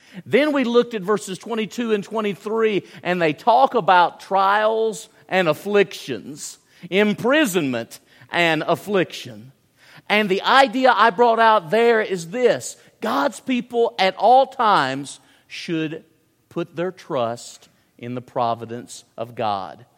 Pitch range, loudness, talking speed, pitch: 155-225 Hz, -19 LUFS, 125 wpm, 190 Hz